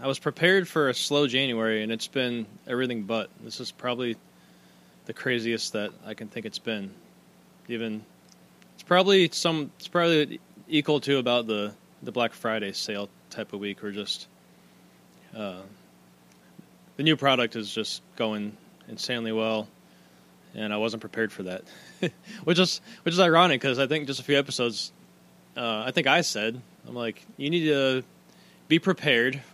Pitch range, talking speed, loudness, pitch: 100-140 Hz, 165 wpm, -26 LUFS, 115 Hz